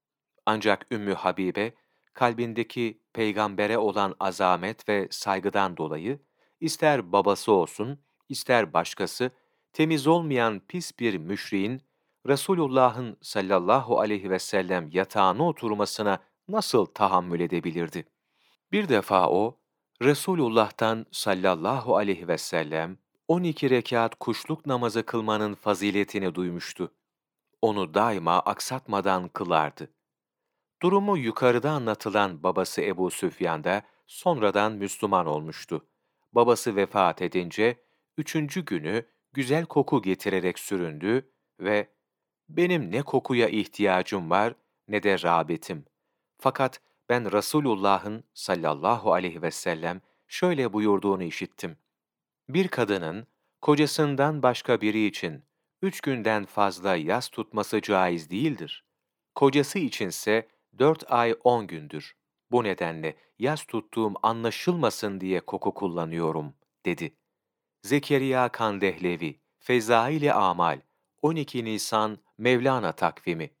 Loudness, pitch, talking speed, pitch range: -26 LUFS, 110 Hz, 100 wpm, 100-135 Hz